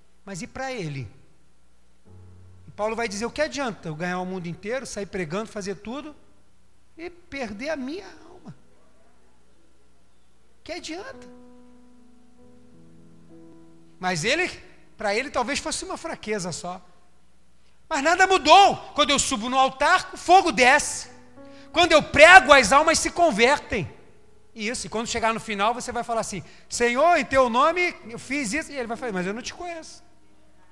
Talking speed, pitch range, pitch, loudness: 160 wpm, 185-305 Hz, 245 Hz, -21 LUFS